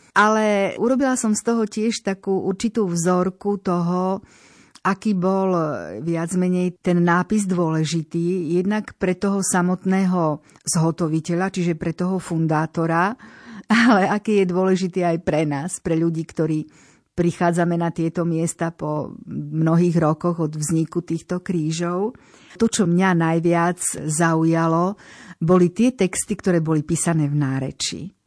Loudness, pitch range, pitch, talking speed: -21 LUFS, 165-190 Hz, 175 Hz, 125 wpm